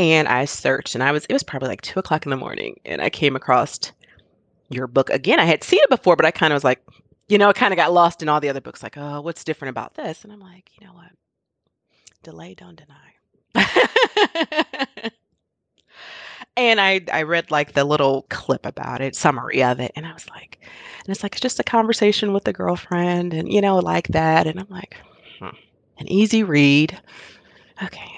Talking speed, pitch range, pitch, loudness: 210 wpm, 140-205 Hz, 165 Hz, -19 LUFS